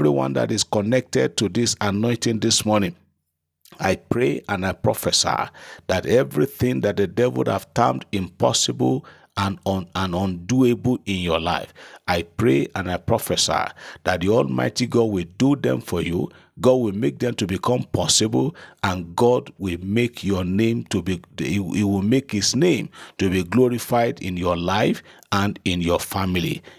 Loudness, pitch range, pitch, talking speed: -21 LUFS, 90-120 Hz, 100 Hz, 170 wpm